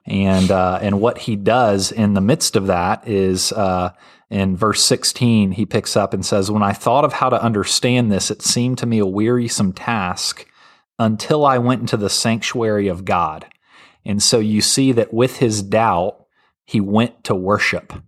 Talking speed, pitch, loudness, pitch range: 185 wpm, 105 Hz, -17 LUFS, 100-120 Hz